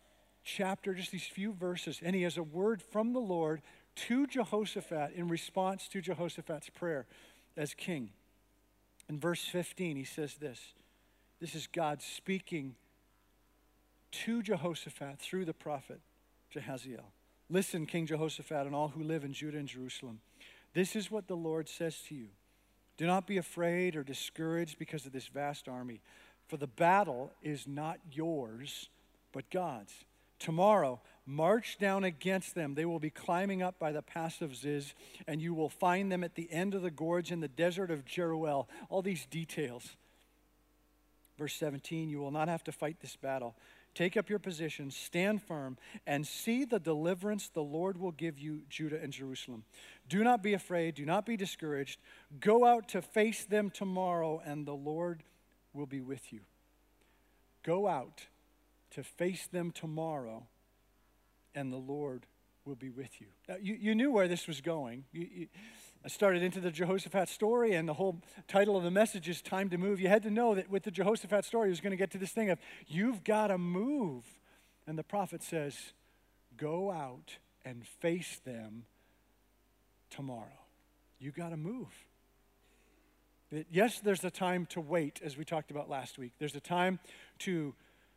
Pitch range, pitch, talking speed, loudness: 145-190 Hz, 165 Hz, 170 wpm, -36 LUFS